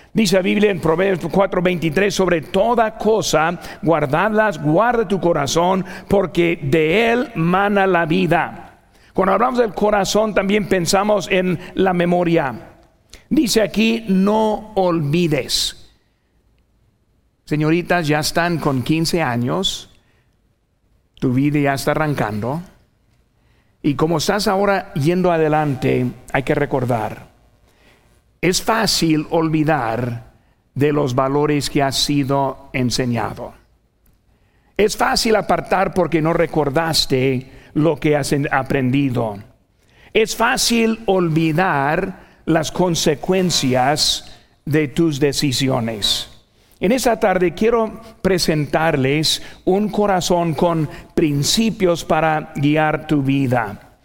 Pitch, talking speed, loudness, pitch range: 165 Hz, 105 wpm, -18 LUFS, 145-190 Hz